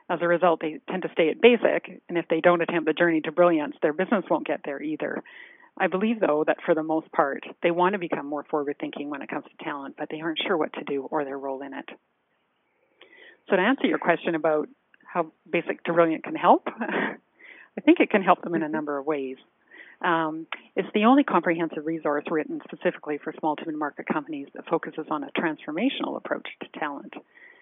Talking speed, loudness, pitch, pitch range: 220 wpm, -25 LUFS, 170 Hz, 155-210 Hz